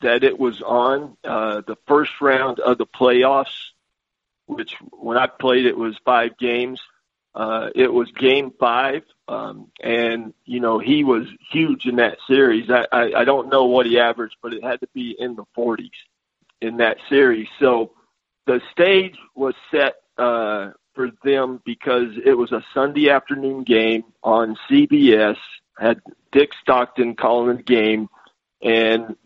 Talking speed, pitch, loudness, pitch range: 160 wpm, 125 Hz, -19 LUFS, 115-135 Hz